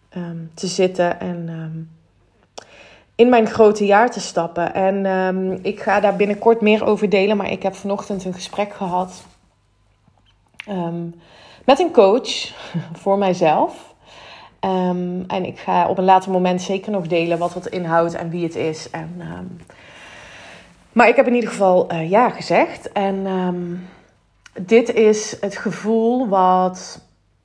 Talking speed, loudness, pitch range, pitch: 150 wpm, -18 LUFS, 170-205 Hz, 185 Hz